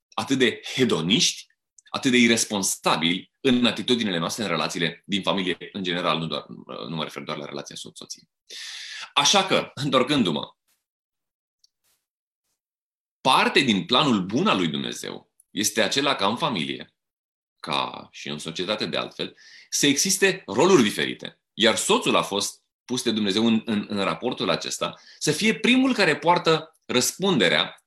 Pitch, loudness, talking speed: 110 Hz, -22 LUFS, 145 wpm